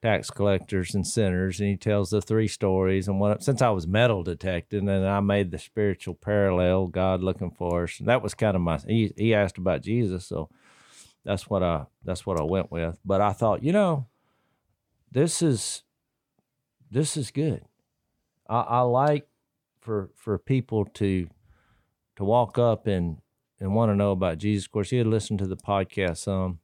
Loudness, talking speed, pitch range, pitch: -26 LUFS, 190 wpm, 95-115 Hz, 100 Hz